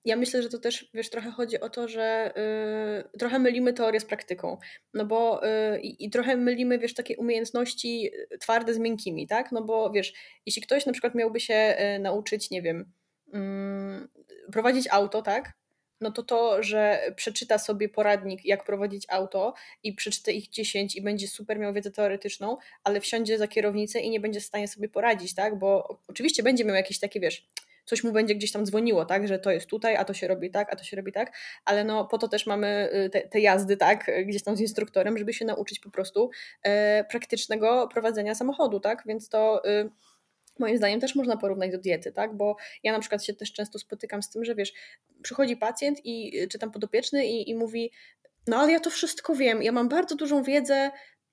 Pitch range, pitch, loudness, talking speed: 205-235 Hz, 215 Hz, -27 LUFS, 200 wpm